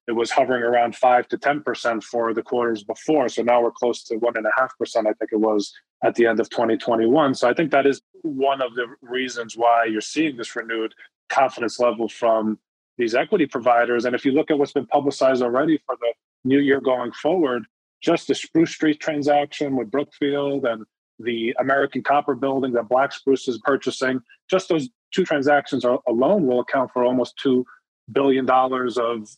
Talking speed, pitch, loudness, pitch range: 190 wpm, 130 Hz, -21 LUFS, 120-140 Hz